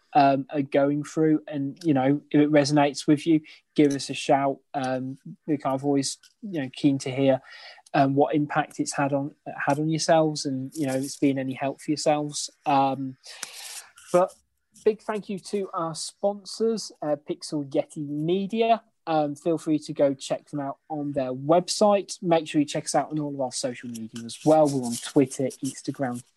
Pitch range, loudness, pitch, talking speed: 135-160 Hz, -25 LUFS, 145 Hz, 190 wpm